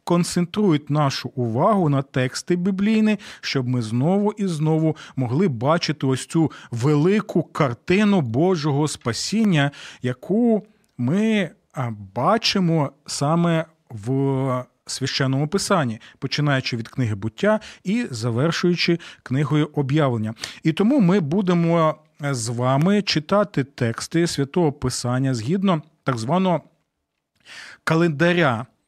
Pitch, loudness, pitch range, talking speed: 155 Hz, -21 LUFS, 130-180 Hz, 100 wpm